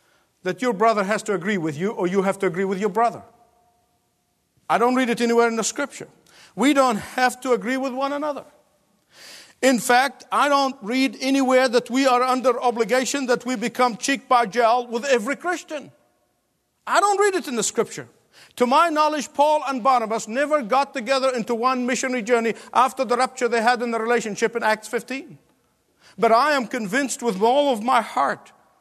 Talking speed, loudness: 190 wpm, -21 LUFS